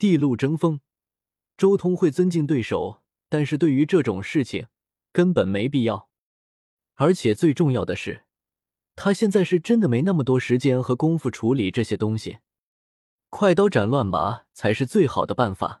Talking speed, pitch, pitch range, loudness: 245 characters per minute, 145 Hz, 115-180 Hz, -22 LUFS